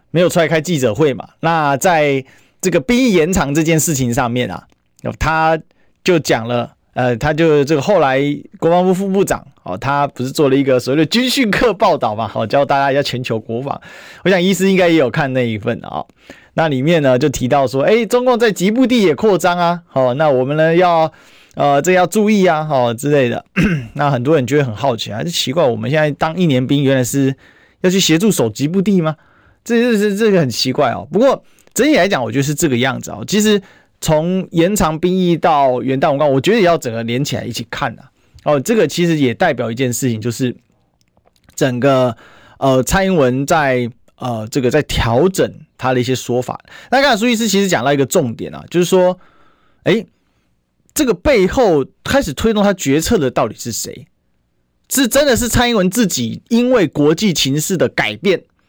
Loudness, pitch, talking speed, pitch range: -15 LUFS, 150 Hz, 295 characters per minute, 125-185 Hz